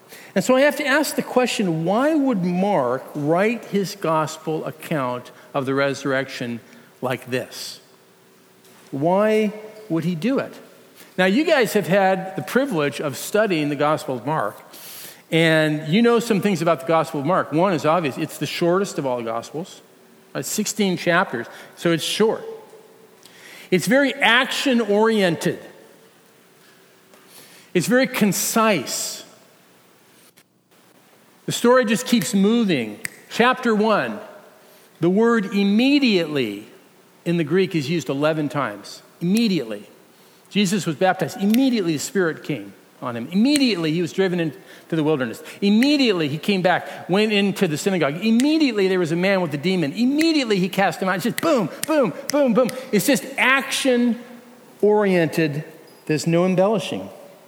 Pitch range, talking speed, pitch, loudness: 155-225 Hz, 145 wpm, 190 Hz, -20 LUFS